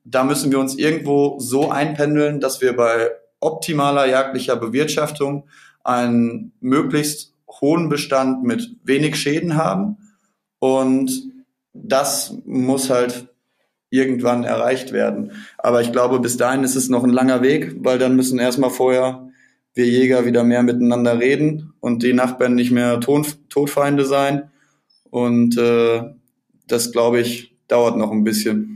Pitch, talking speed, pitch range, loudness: 130 Hz, 140 wpm, 120-145 Hz, -18 LUFS